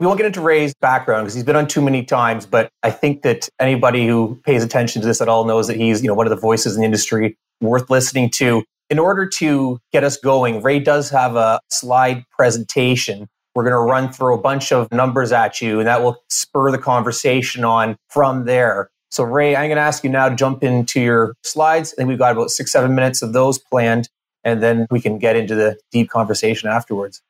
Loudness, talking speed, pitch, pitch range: -16 LUFS, 230 wpm, 125 Hz, 115-135 Hz